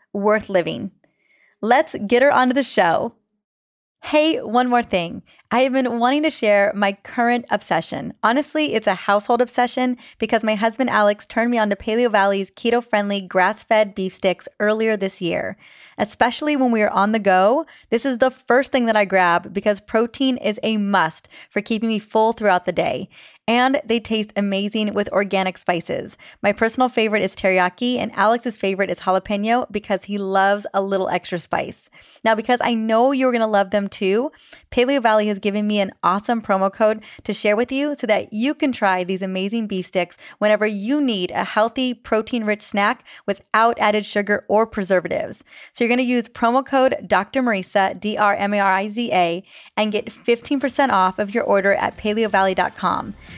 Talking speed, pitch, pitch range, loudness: 170 wpm, 215 Hz, 200-240 Hz, -19 LUFS